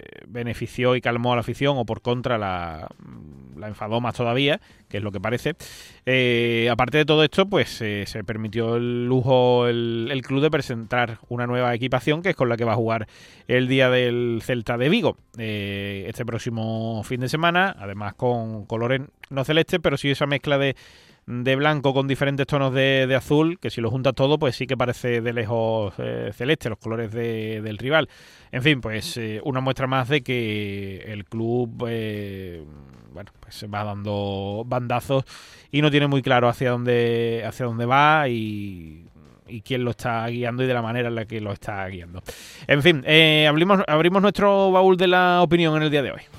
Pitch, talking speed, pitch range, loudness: 120 Hz, 200 wpm, 110-135 Hz, -22 LUFS